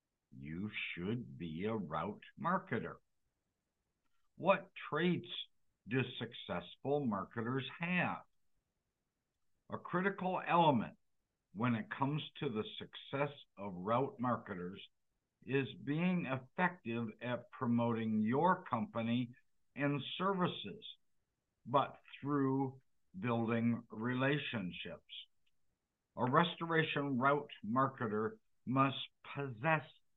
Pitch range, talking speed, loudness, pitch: 115-160 Hz, 85 wpm, -38 LUFS, 135 Hz